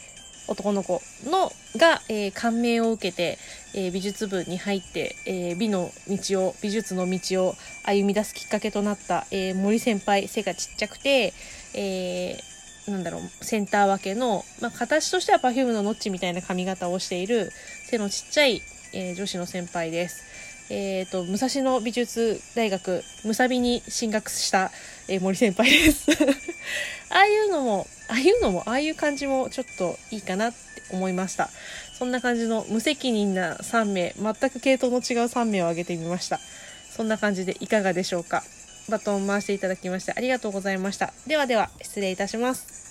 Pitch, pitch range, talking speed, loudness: 205 Hz, 190-240 Hz, 350 characters per minute, -25 LUFS